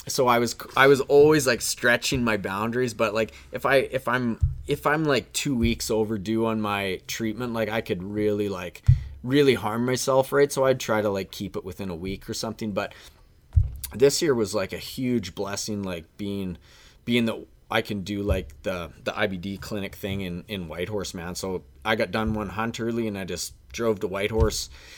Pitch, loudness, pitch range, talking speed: 105 Hz, -25 LUFS, 95-120 Hz, 200 wpm